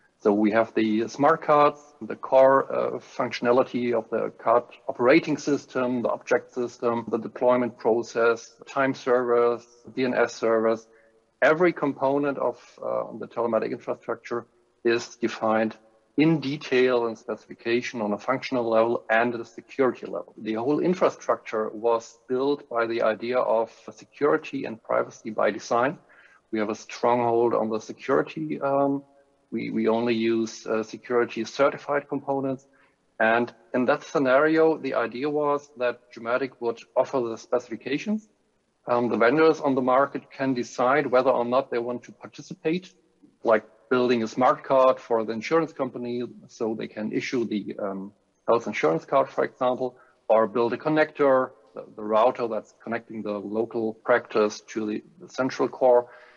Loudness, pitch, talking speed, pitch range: -25 LUFS, 120 Hz, 150 wpm, 115-135 Hz